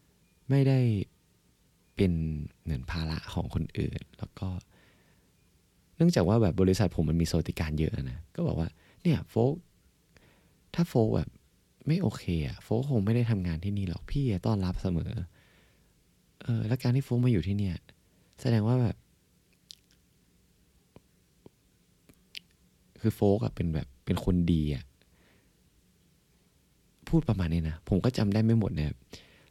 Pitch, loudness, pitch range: 95 Hz, -30 LUFS, 85-115 Hz